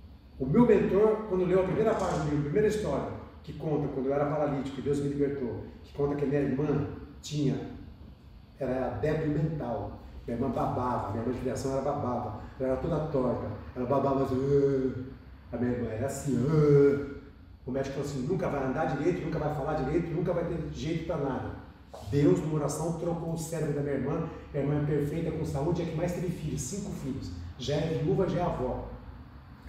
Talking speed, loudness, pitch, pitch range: 200 wpm, -30 LUFS, 140 Hz, 130-160 Hz